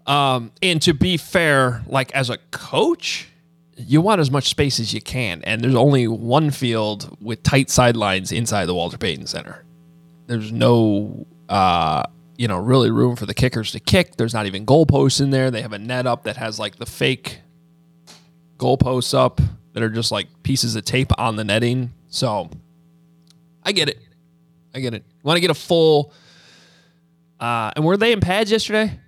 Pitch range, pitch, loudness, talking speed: 115-165 Hz, 135 Hz, -19 LUFS, 190 wpm